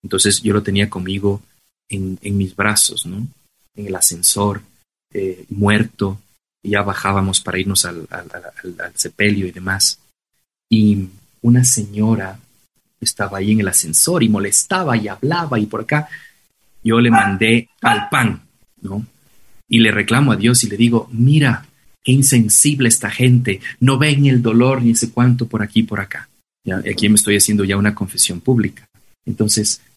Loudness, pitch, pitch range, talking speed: -15 LUFS, 105 Hz, 100-120 Hz, 160 wpm